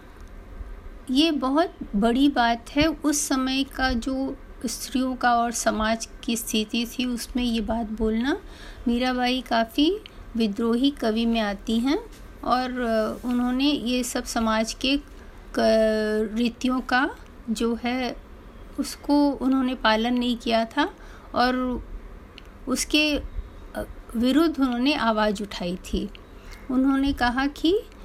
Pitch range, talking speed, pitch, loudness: 225-270 Hz, 115 wpm, 245 Hz, -24 LUFS